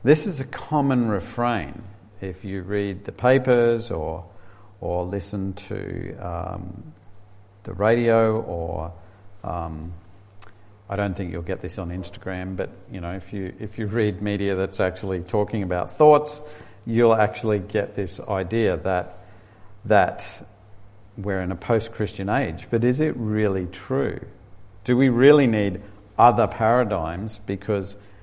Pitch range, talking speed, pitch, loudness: 95-115 Hz, 140 wpm, 100 Hz, -23 LUFS